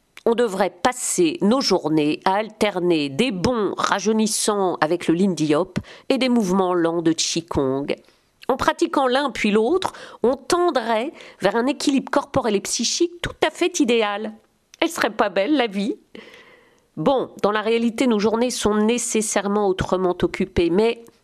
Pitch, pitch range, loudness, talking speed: 220 Hz, 190-270 Hz, -21 LUFS, 155 wpm